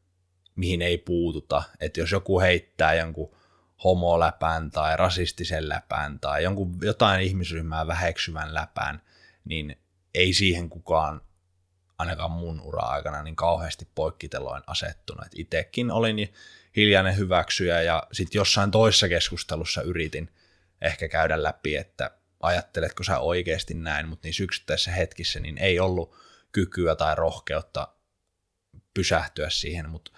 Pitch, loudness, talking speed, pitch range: 90 Hz, -25 LUFS, 115 wpm, 80-95 Hz